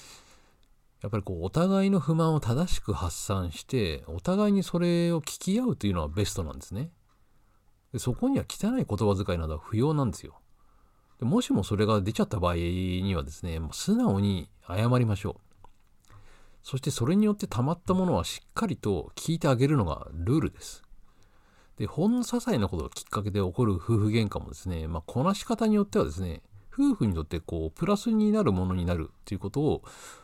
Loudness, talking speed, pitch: -28 LUFS, 385 characters per minute, 105 Hz